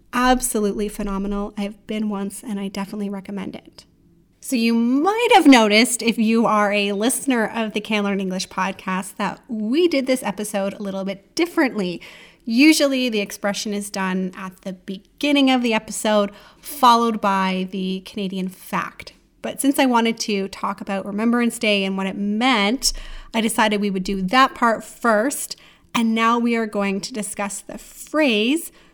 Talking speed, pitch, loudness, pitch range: 165 wpm, 210 Hz, -20 LUFS, 200-235 Hz